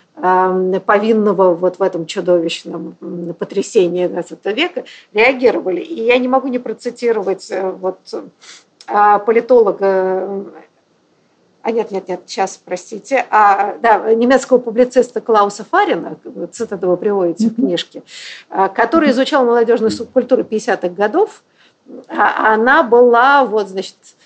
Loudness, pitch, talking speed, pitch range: -14 LUFS, 210 Hz, 110 wpm, 185-240 Hz